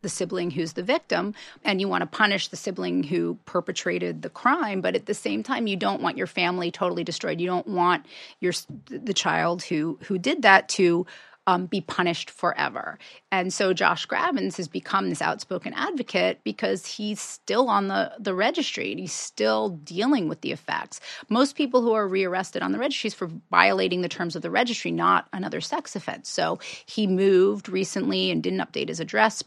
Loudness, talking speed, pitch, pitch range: -25 LUFS, 190 wpm, 185 Hz, 170-210 Hz